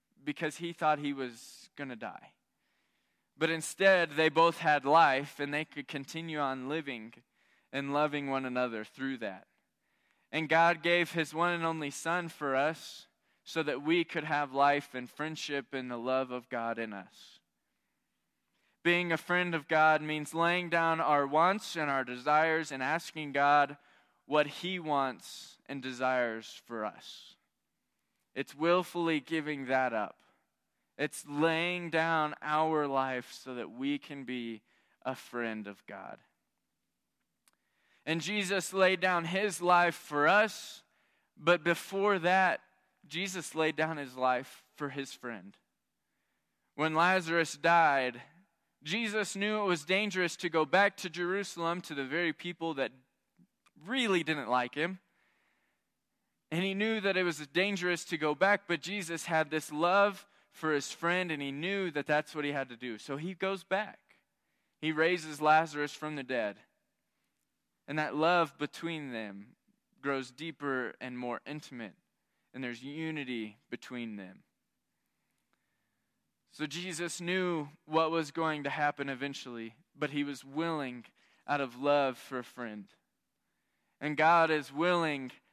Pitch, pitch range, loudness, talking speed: 155 Hz, 140-175 Hz, -32 LUFS, 145 wpm